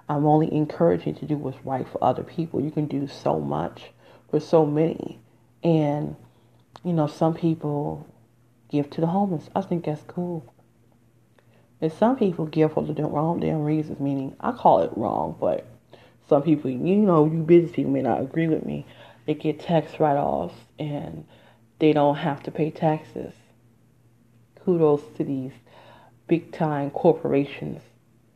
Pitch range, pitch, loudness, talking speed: 120-160 Hz, 150 Hz, -24 LUFS, 160 wpm